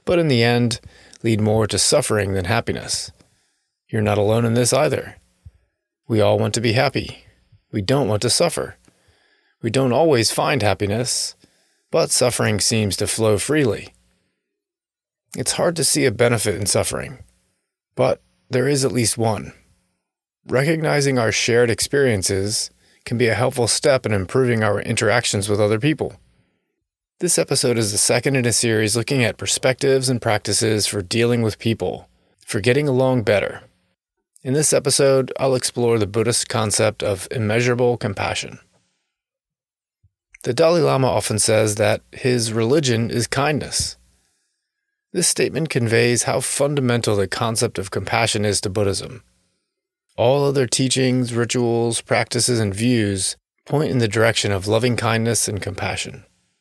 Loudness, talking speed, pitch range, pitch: -19 LUFS, 145 wpm, 105-130 Hz, 115 Hz